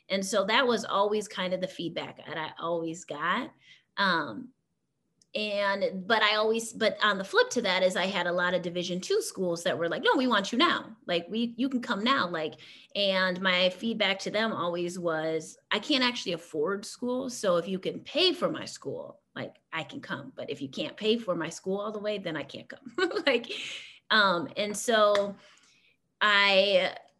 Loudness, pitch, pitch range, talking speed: -28 LUFS, 200 Hz, 180-235 Hz, 205 wpm